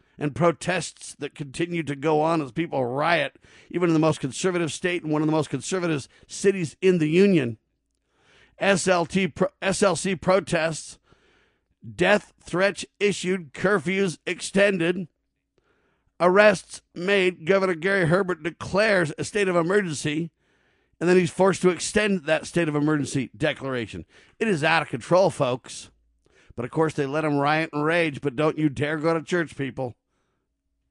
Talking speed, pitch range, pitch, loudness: 150 wpm, 150-185 Hz, 165 Hz, -23 LUFS